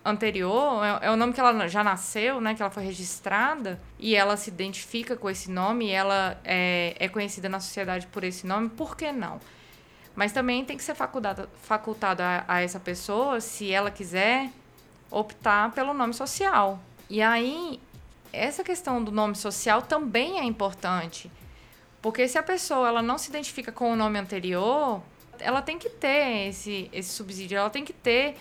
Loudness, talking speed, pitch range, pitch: -27 LUFS, 175 wpm, 195-255 Hz, 215 Hz